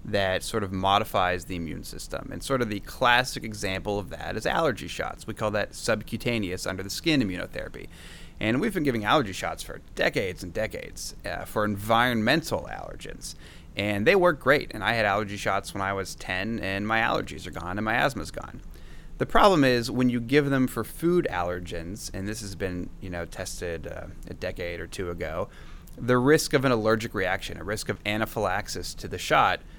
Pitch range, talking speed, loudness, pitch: 95-115 Hz, 195 wpm, -27 LUFS, 105 Hz